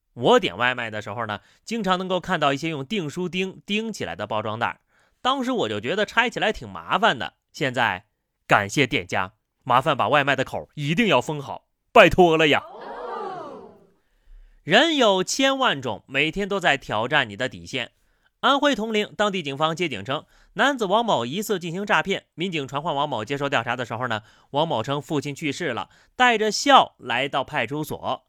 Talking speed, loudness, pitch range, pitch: 270 characters per minute, -22 LUFS, 140-210 Hz, 160 Hz